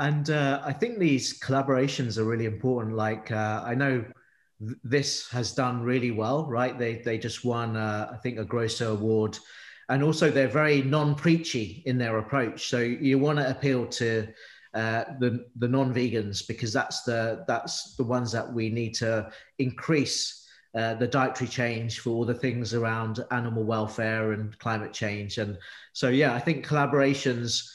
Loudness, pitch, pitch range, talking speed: -27 LUFS, 120 Hz, 110-135 Hz, 175 wpm